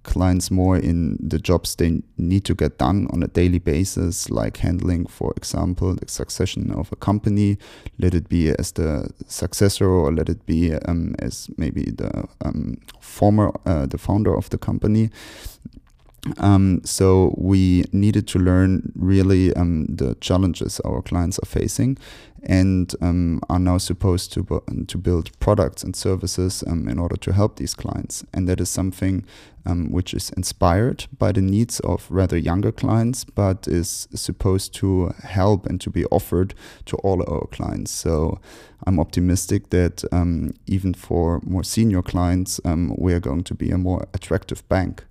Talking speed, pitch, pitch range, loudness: 170 wpm, 90 Hz, 85-100 Hz, -21 LUFS